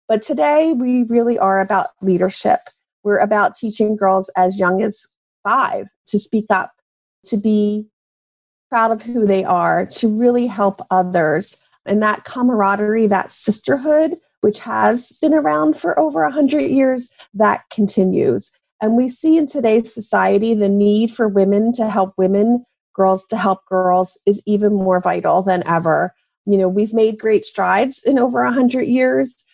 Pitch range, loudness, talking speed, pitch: 190-235 Hz, -17 LUFS, 155 wpm, 210 Hz